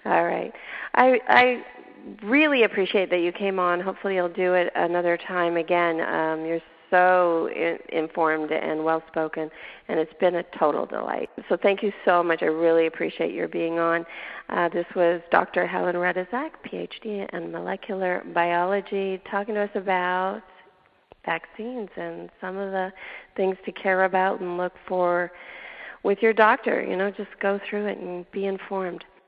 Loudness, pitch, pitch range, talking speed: -24 LUFS, 185 Hz, 170-200 Hz, 160 wpm